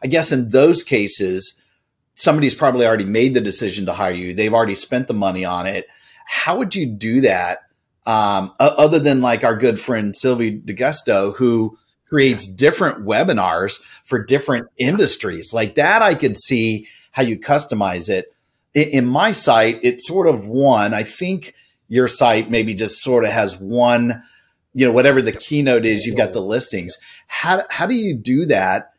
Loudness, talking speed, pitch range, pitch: -17 LUFS, 175 wpm, 110-135 Hz, 120 Hz